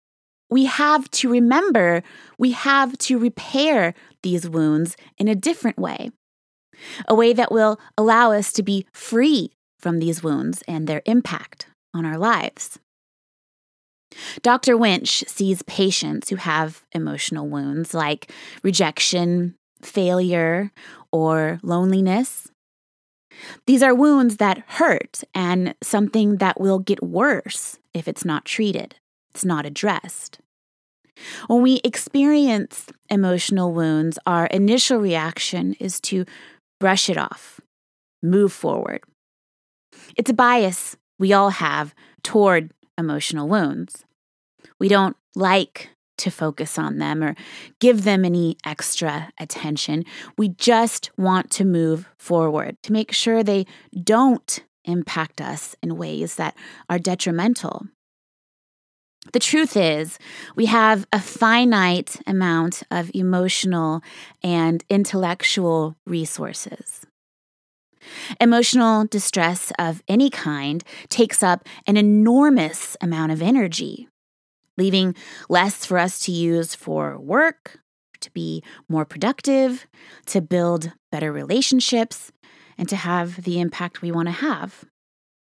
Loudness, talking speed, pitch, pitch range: -20 LUFS, 120 wpm, 190 Hz, 170-230 Hz